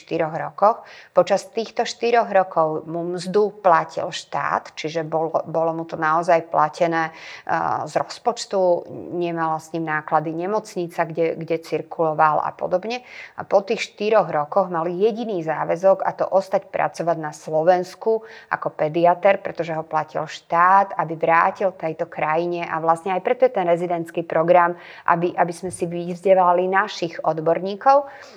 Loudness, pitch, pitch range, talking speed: -21 LUFS, 175 Hz, 165-195 Hz, 145 wpm